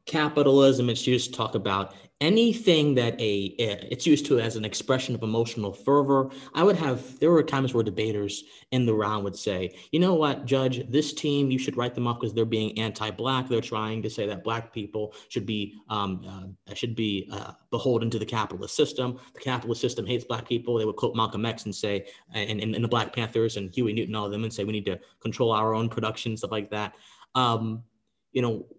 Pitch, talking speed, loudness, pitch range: 115 Hz, 210 wpm, -26 LUFS, 105-130 Hz